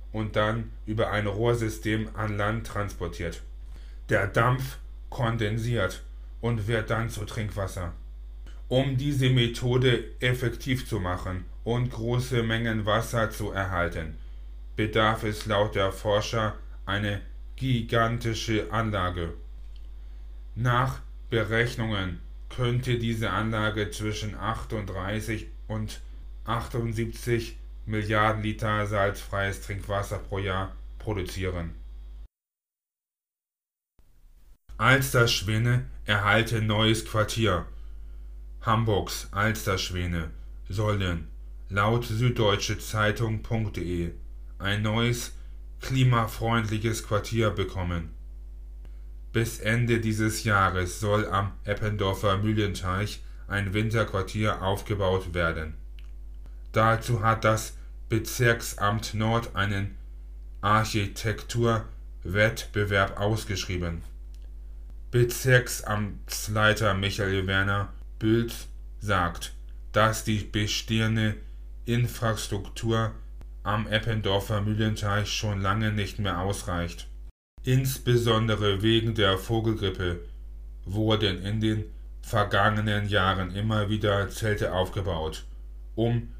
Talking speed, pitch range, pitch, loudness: 80 wpm, 85-110 Hz, 105 Hz, -27 LUFS